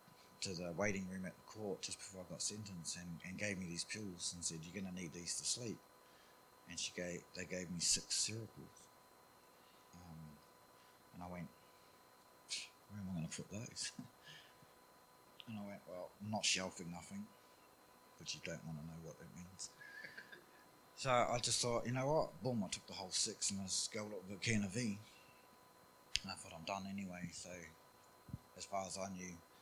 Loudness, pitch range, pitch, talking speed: -43 LUFS, 85-100 Hz, 90 Hz, 195 wpm